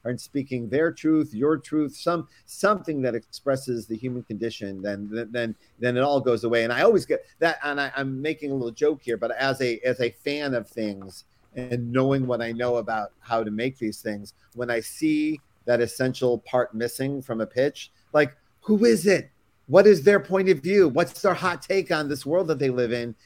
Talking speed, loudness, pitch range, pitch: 215 wpm, -24 LUFS, 115-155 Hz, 130 Hz